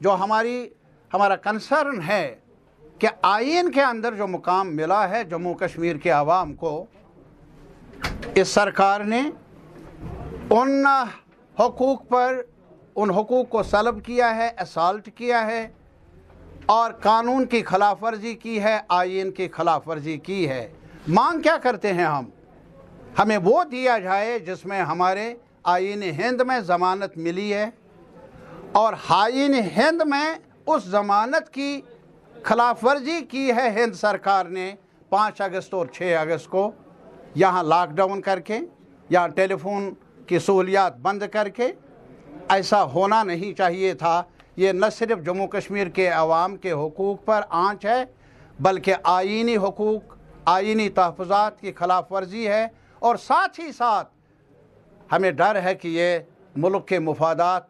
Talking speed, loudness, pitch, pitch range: 140 wpm, -22 LUFS, 200 Hz, 180-230 Hz